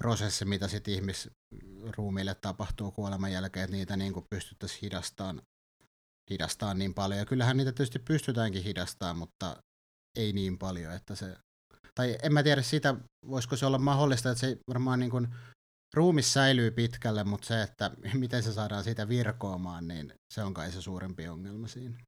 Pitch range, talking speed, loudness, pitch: 95-125 Hz, 165 wpm, -32 LUFS, 105 Hz